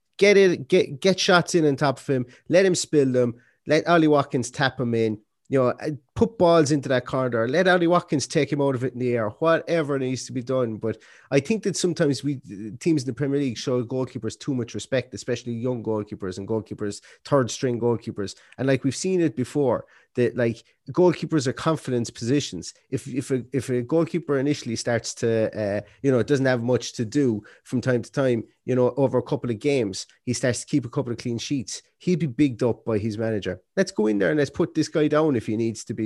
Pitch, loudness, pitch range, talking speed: 130 Hz, -24 LUFS, 120-150 Hz, 230 wpm